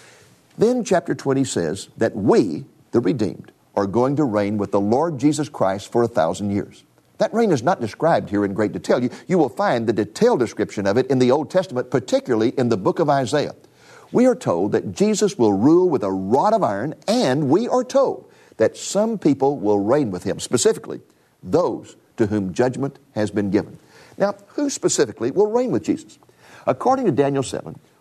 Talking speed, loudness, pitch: 195 wpm, -20 LUFS, 135 Hz